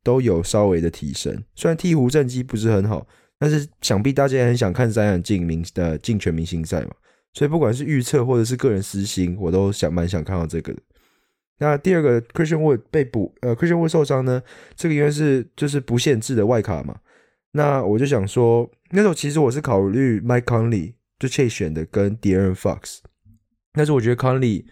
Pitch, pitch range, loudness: 120 Hz, 95-140 Hz, -20 LUFS